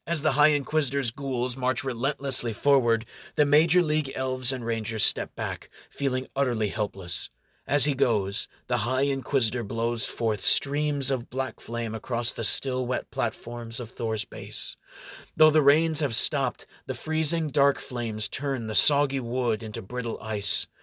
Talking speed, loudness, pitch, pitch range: 160 wpm, -25 LUFS, 130 Hz, 115-140 Hz